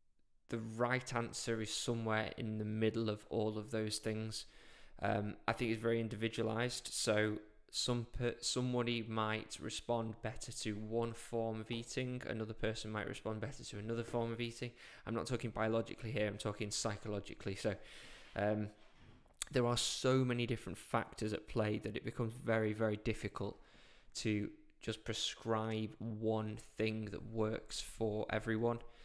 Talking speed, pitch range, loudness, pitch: 155 wpm, 110-120 Hz, -40 LUFS, 110 Hz